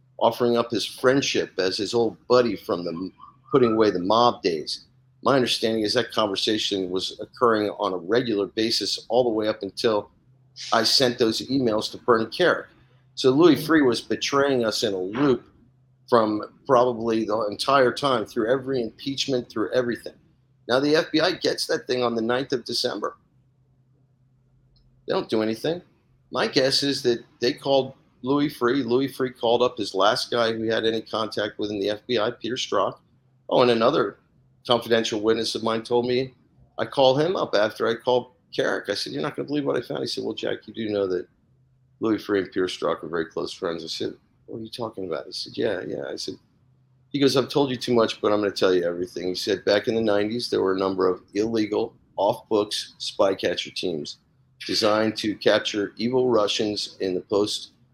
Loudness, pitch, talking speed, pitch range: -24 LUFS, 120 Hz, 200 wpm, 110-130 Hz